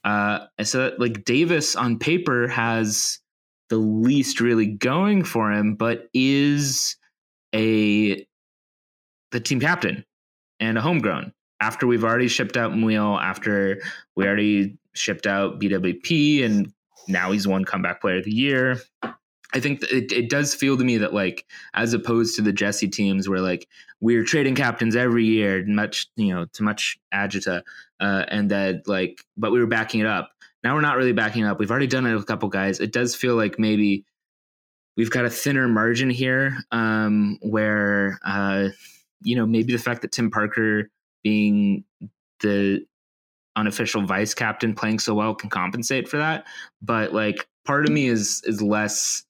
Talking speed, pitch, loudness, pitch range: 170 wpm, 110 Hz, -22 LUFS, 100-120 Hz